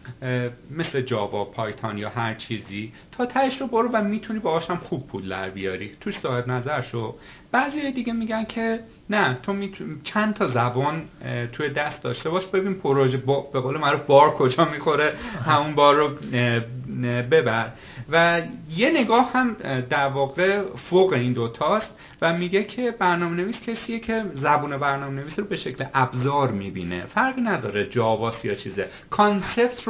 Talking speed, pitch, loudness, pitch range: 160 wpm, 145 Hz, -23 LUFS, 125-200 Hz